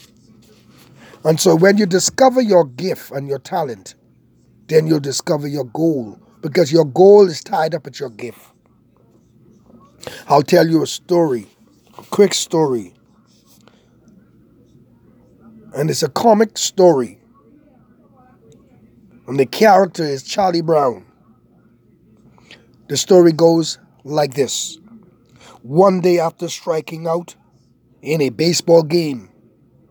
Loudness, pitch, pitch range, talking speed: -15 LUFS, 165 Hz, 135-180 Hz, 115 wpm